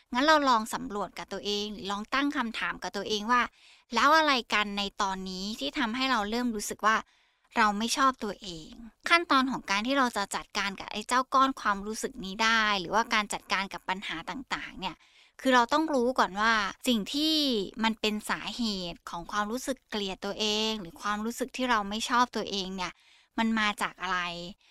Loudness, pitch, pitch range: -28 LUFS, 215 Hz, 200-245 Hz